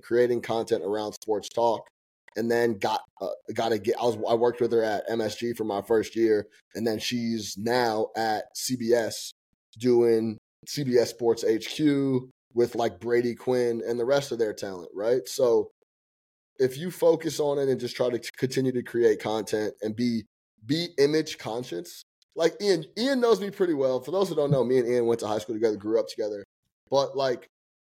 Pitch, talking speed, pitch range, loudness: 120 Hz, 190 wpm, 115-150 Hz, -27 LUFS